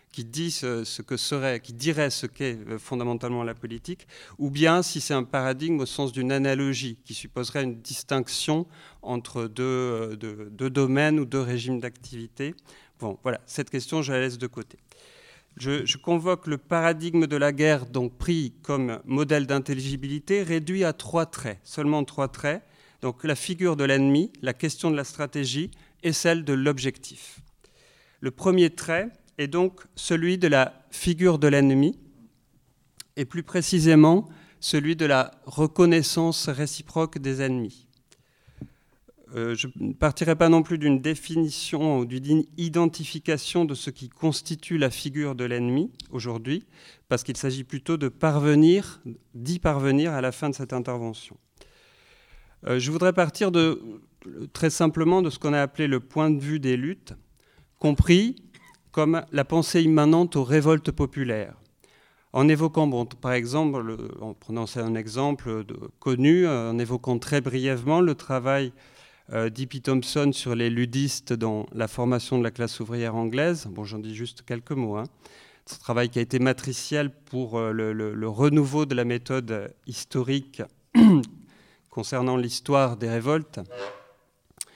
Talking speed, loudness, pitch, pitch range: 155 wpm, -25 LUFS, 140 Hz, 125-160 Hz